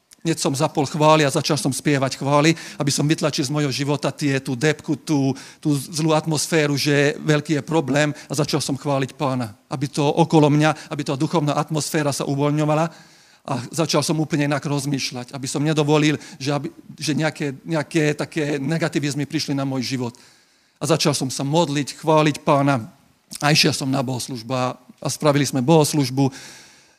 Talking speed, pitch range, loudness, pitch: 170 wpm, 140-155 Hz, -21 LUFS, 150 Hz